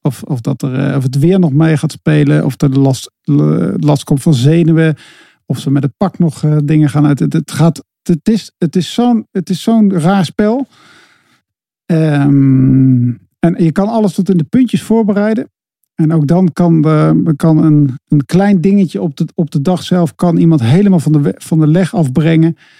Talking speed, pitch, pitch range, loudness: 205 wpm, 160 Hz, 150-185 Hz, -11 LUFS